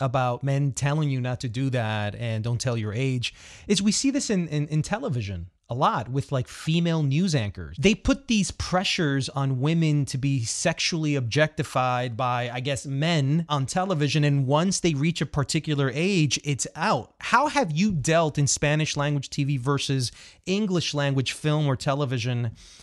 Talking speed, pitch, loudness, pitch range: 175 wpm, 145 Hz, -25 LUFS, 130-165 Hz